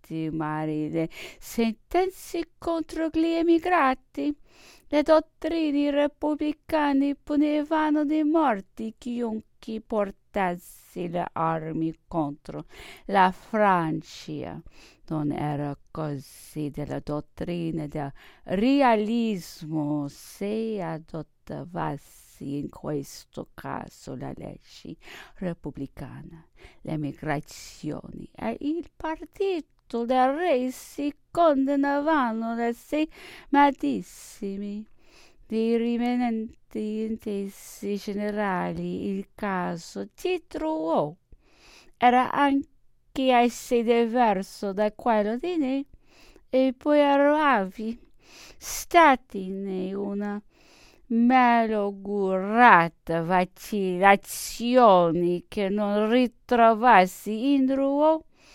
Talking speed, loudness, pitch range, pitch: 75 wpm, -25 LUFS, 175-285 Hz, 225 Hz